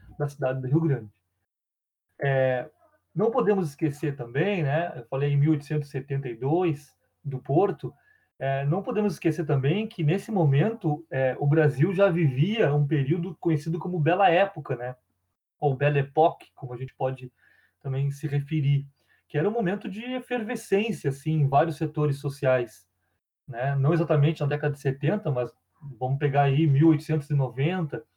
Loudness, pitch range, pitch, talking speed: -26 LUFS, 135-165 Hz, 150 Hz, 150 wpm